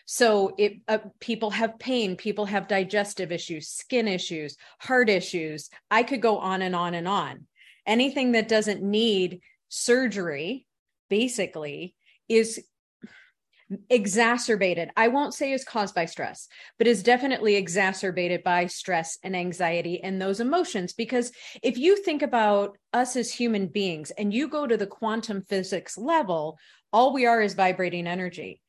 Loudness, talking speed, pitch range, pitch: -25 LUFS, 150 wpm, 185-235 Hz, 210 Hz